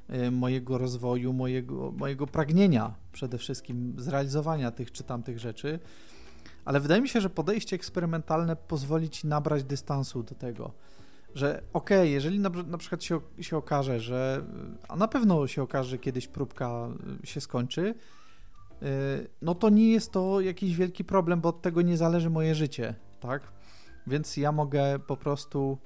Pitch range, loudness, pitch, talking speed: 130-170 Hz, -29 LUFS, 145 Hz, 155 wpm